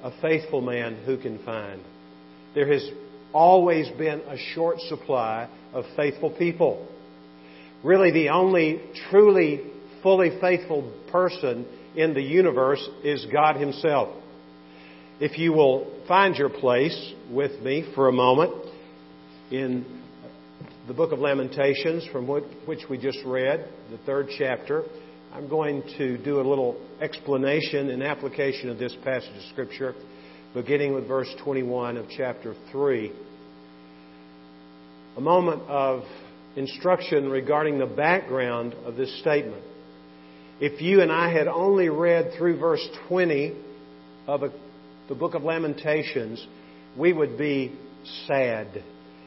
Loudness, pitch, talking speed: -24 LUFS, 140 Hz, 125 wpm